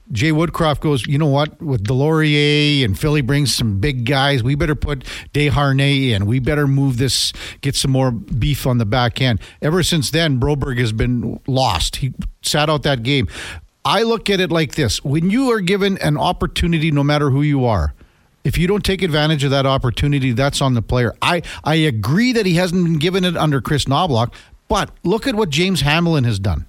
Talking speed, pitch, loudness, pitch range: 205 wpm, 140 Hz, -17 LUFS, 125-160 Hz